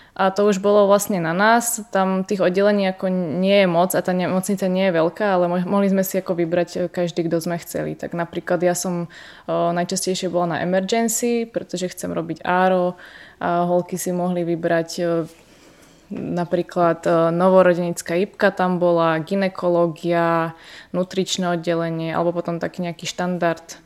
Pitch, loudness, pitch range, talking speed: 180 Hz, -20 LUFS, 170-190 Hz, 155 wpm